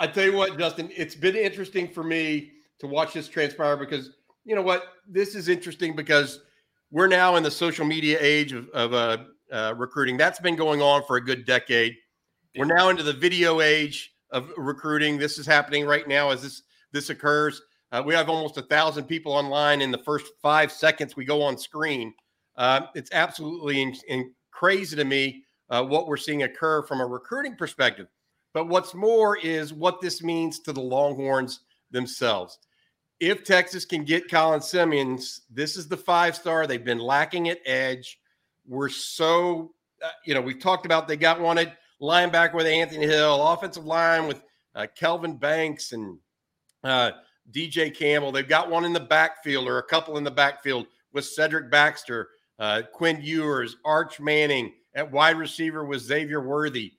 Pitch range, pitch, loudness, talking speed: 140-165 Hz, 150 Hz, -24 LUFS, 180 wpm